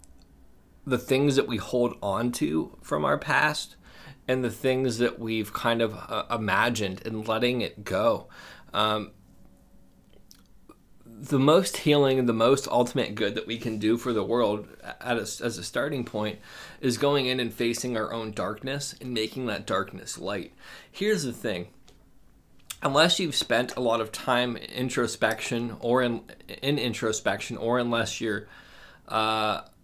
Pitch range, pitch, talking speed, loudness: 110-125 Hz, 115 Hz, 155 wpm, -27 LUFS